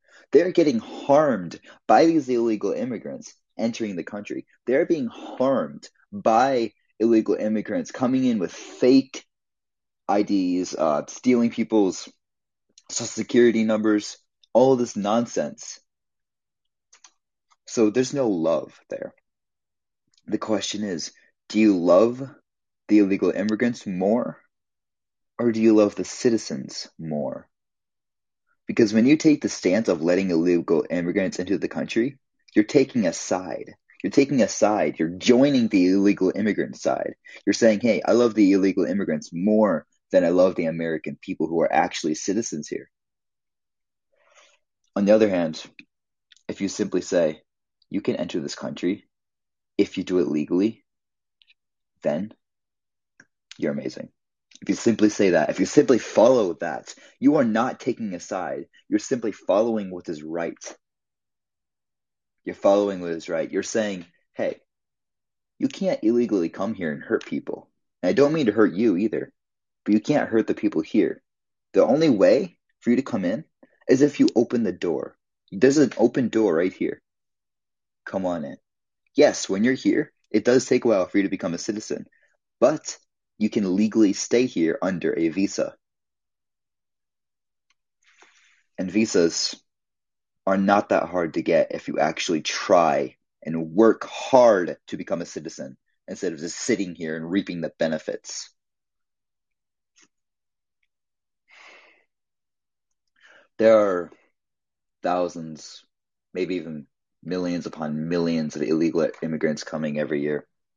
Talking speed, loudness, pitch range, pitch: 140 wpm, -23 LUFS, 90-115 Hz, 105 Hz